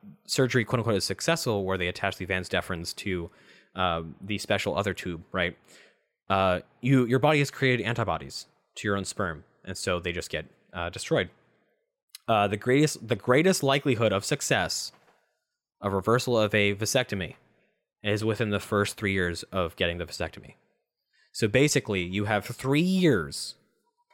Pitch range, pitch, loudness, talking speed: 95-130 Hz, 105 Hz, -27 LUFS, 160 wpm